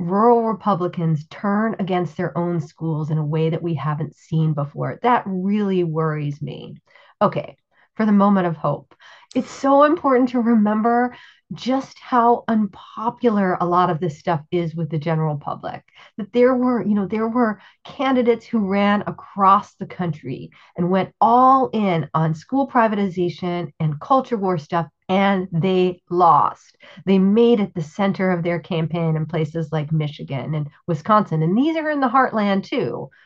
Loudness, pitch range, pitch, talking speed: -20 LUFS, 165-225 Hz, 185 Hz, 165 wpm